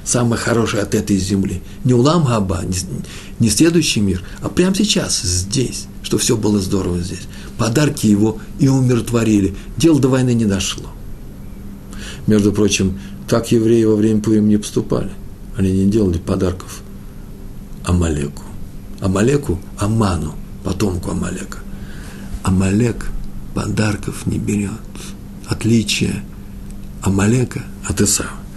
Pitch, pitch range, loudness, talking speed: 100 Hz, 95-115 Hz, -17 LUFS, 115 wpm